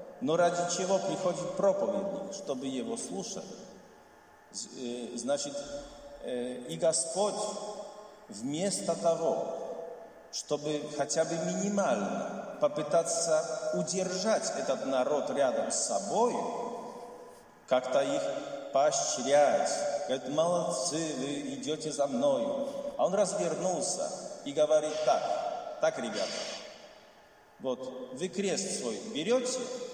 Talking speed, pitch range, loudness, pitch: 90 wpm, 155-235 Hz, -31 LUFS, 180 Hz